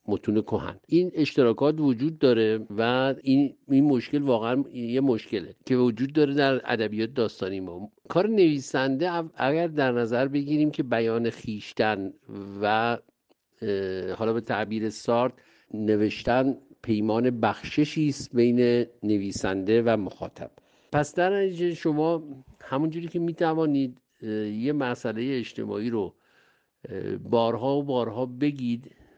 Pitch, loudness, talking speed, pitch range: 125 Hz, -26 LUFS, 115 wpm, 110-145 Hz